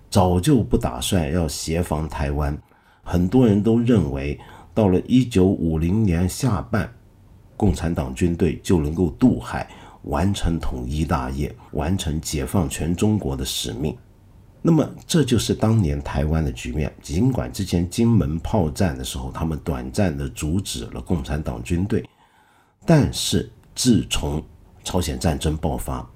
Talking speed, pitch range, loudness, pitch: 225 characters per minute, 75-100 Hz, -22 LUFS, 90 Hz